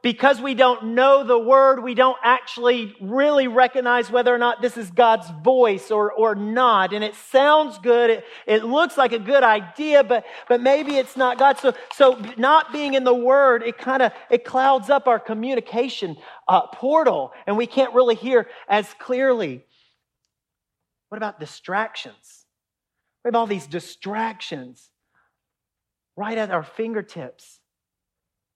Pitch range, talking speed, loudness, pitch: 215-265 Hz, 155 wpm, -19 LUFS, 240 Hz